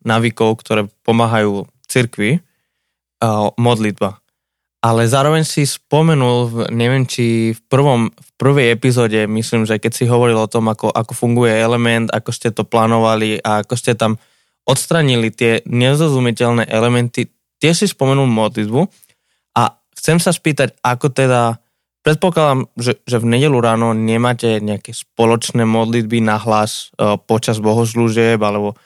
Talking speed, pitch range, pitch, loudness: 135 wpm, 110-125 Hz, 115 Hz, -15 LUFS